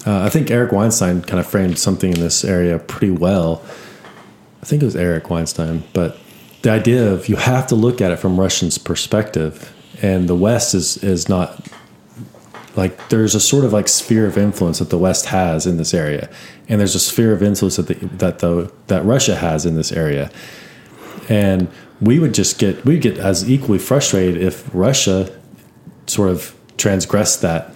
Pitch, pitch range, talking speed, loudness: 95 Hz, 90-110 Hz, 190 wpm, -16 LUFS